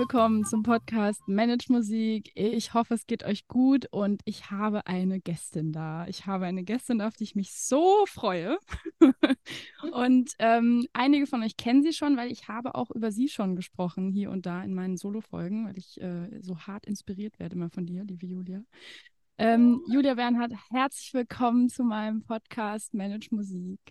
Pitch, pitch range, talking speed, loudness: 220 Hz, 195-245 Hz, 180 wpm, -28 LUFS